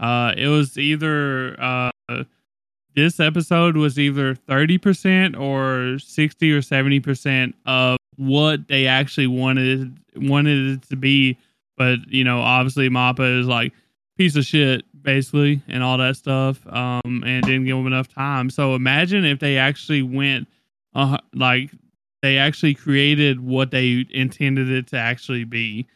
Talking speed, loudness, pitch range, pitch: 150 wpm, -19 LUFS, 130-145 Hz, 135 Hz